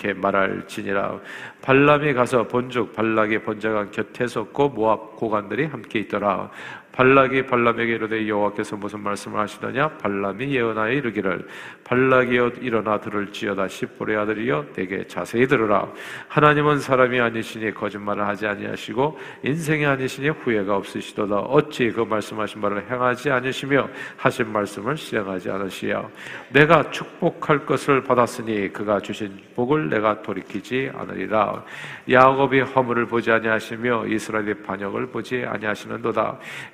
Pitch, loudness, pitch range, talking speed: 115 Hz, -22 LUFS, 105-130 Hz, 360 characters per minute